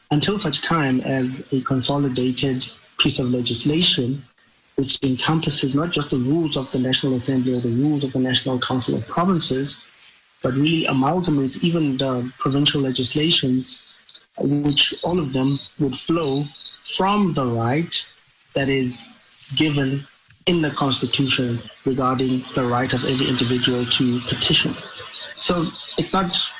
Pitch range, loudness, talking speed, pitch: 130-150 Hz, -20 LUFS, 140 wpm, 135 Hz